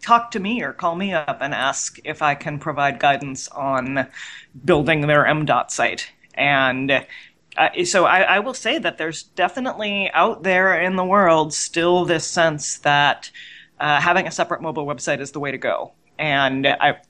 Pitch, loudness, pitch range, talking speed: 160 Hz, -19 LUFS, 140-190 Hz, 180 wpm